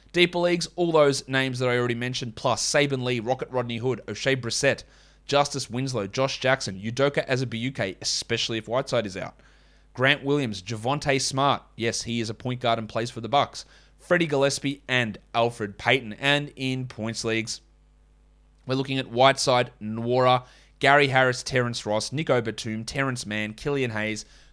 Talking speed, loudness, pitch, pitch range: 165 wpm, -25 LUFS, 125 Hz, 115-135 Hz